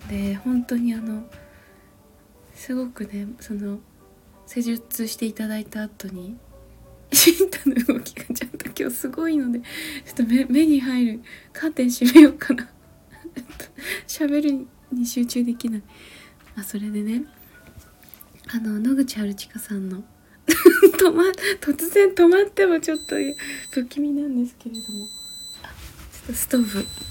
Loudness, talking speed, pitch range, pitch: -21 LUFS, 255 characters per minute, 215-290 Hz, 245 Hz